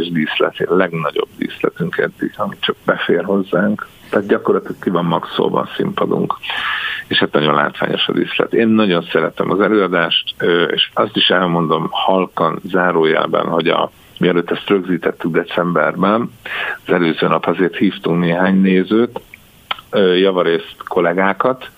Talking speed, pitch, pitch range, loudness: 130 wpm, 90 Hz, 85-100 Hz, -16 LUFS